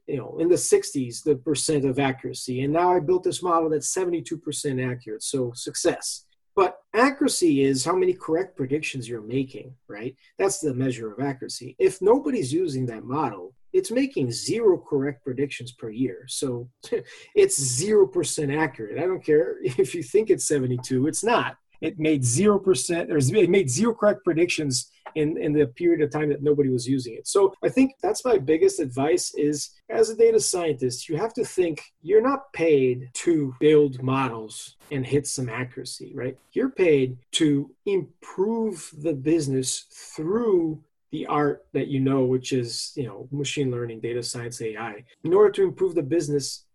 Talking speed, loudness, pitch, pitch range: 175 wpm, -24 LUFS, 150 Hz, 130-200 Hz